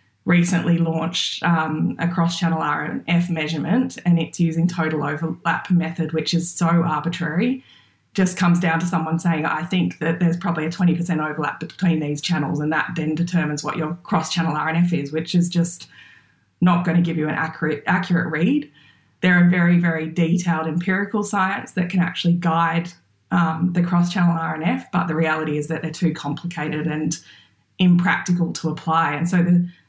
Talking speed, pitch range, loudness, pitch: 170 wpm, 160-175 Hz, -21 LUFS, 170 Hz